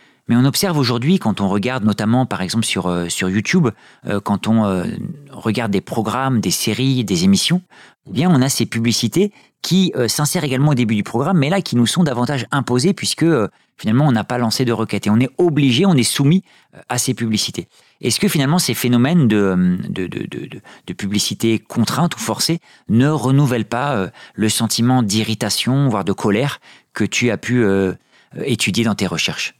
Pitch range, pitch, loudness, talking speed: 110-145 Hz, 120 Hz, -17 LUFS, 200 wpm